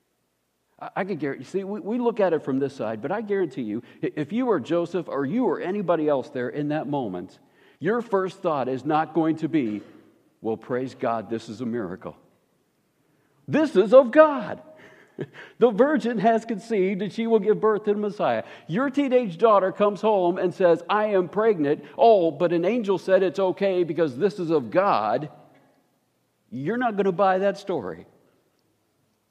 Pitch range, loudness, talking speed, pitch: 140-210 Hz, -23 LUFS, 180 wpm, 180 Hz